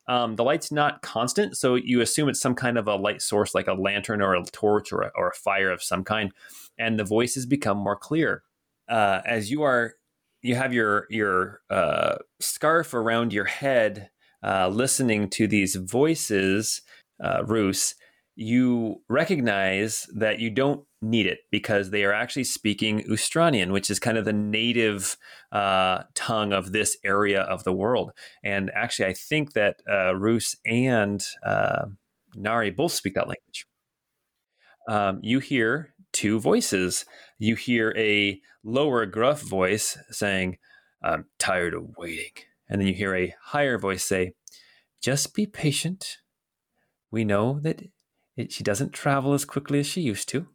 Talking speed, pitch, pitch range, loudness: 160 wpm, 110 Hz, 100-130 Hz, -25 LUFS